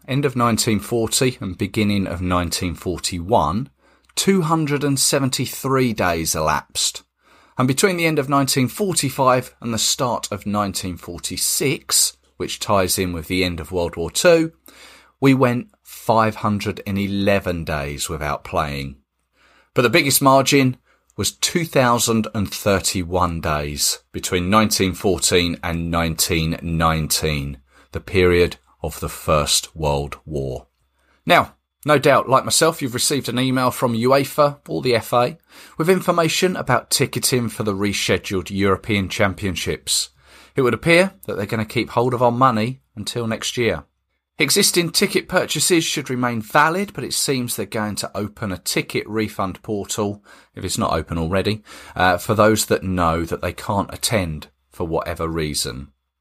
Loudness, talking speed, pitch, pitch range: -19 LUFS, 135 wpm, 105 Hz, 85-130 Hz